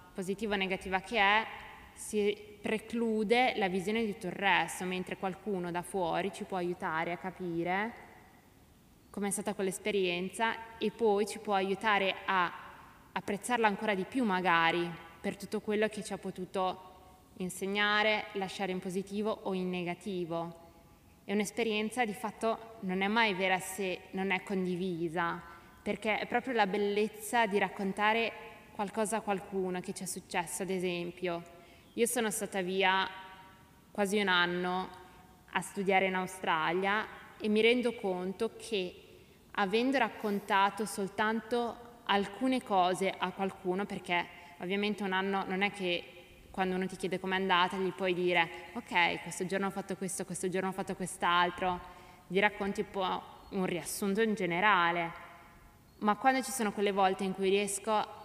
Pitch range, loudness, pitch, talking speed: 185-210 Hz, -32 LUFS, 195 Hz, 150 wpm